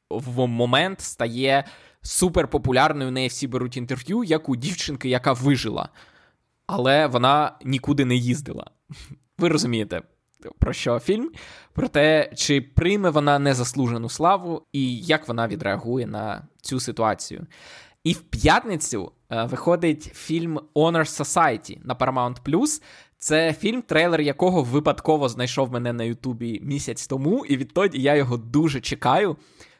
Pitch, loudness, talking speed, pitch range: 140 Hz, -23 LUFS, 130 wpm, 125-155 Hz